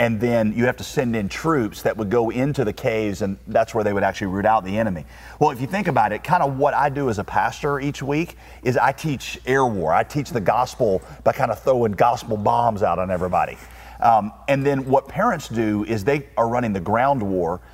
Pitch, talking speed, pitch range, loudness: 115 Hz, 240 wpm, 105-140 Hz, -21 LUFS